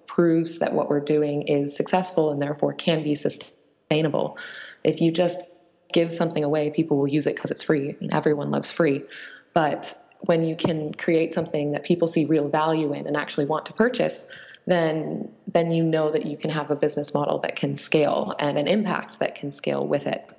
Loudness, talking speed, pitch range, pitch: -24 LUFS, 205 wpm, 150-170 Hz, 155 Hz